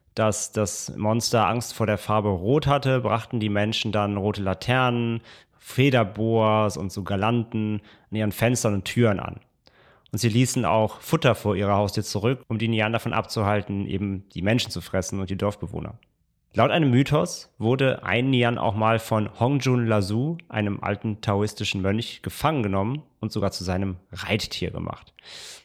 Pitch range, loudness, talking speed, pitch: 100-120 Hz, -24 LUFS, 165 wpm, 110 Hz